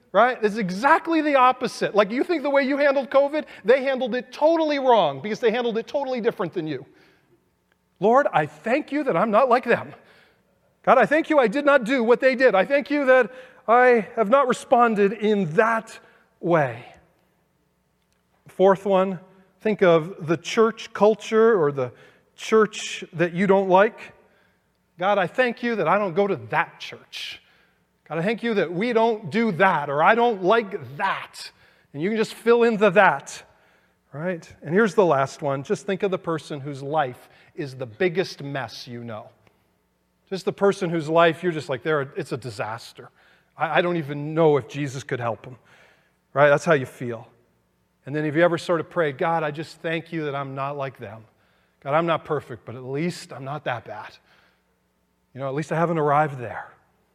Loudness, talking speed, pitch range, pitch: -22 LUFS, 195 wpm, 145-230 Hz, 185 Hz